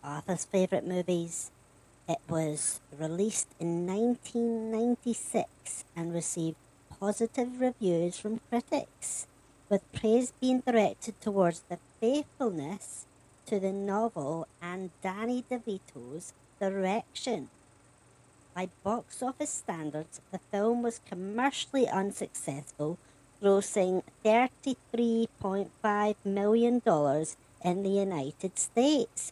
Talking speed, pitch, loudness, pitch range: 90 wpm, 195 Hz, -31 LUFS, 160-230 Hz